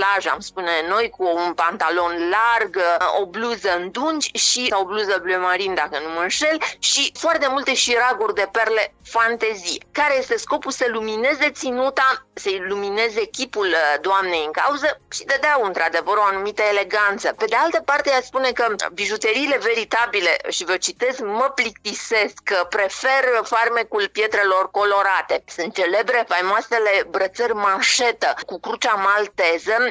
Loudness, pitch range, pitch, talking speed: -19 LUFS, 195-265 Hz, 220 Hz, 145 wpm